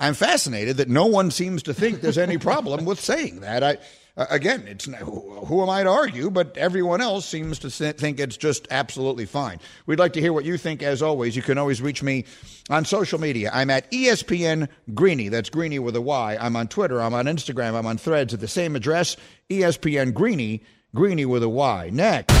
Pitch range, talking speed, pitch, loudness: 130-175 Hz, 210 wpm, 150 Hz, -23 LUFS